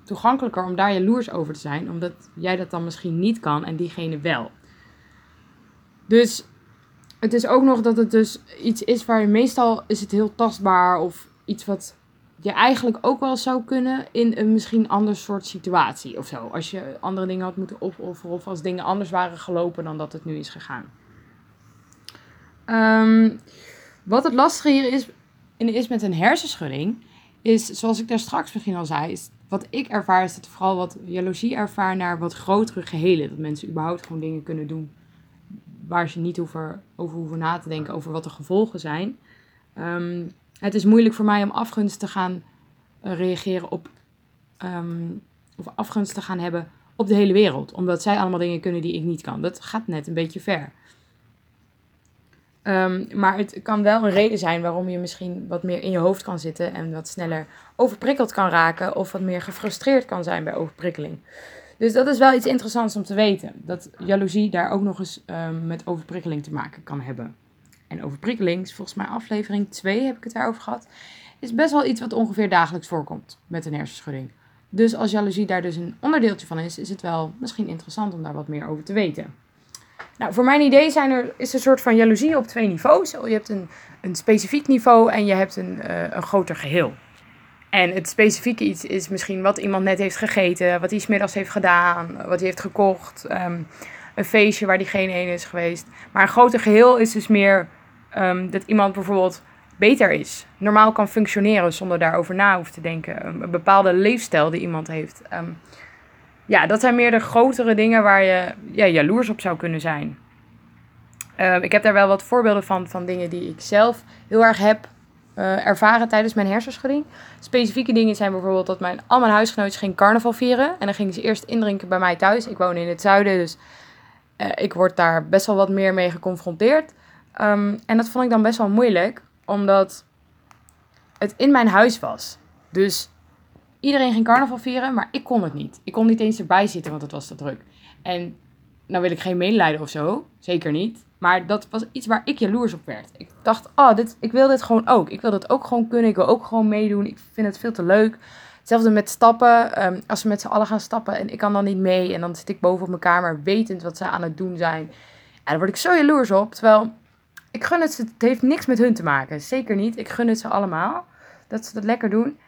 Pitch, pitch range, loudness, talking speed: 195 Hz, 175-225 Hz, -20 LUFS, 210 wpm